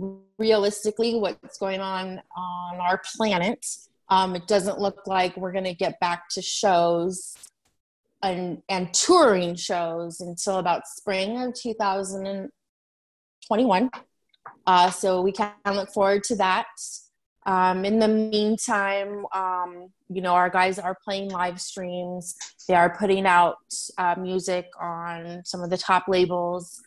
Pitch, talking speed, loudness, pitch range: 190 Hz, 135 wpm, -24 LUFS, 180-200 Hz